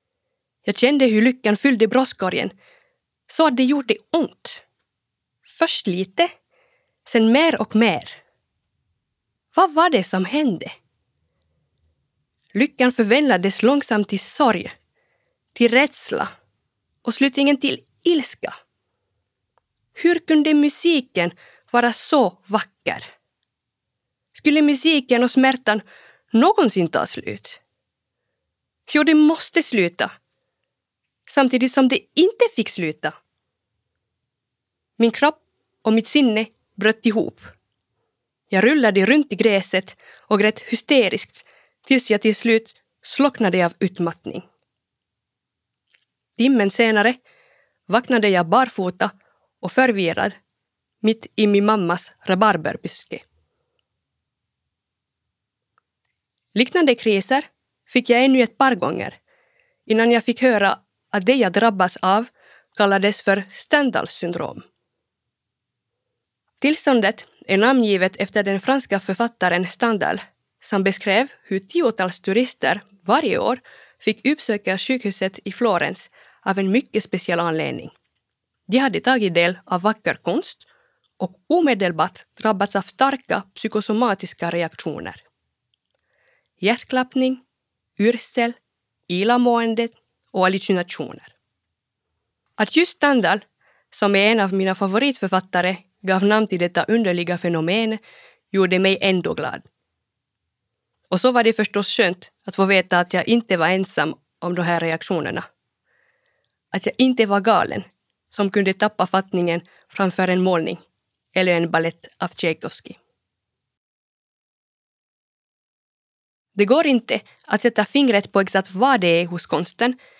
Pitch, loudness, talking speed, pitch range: 215 Hz, -19 LUFS, 110 wpm, 185-255 Hz